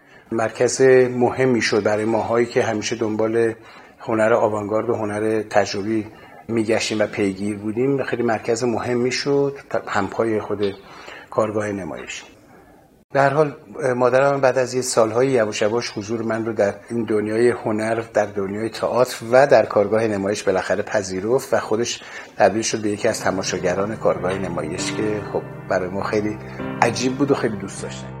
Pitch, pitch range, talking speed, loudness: 115 Hz, 105-125 Hz, 150 wpm, -20 LUFS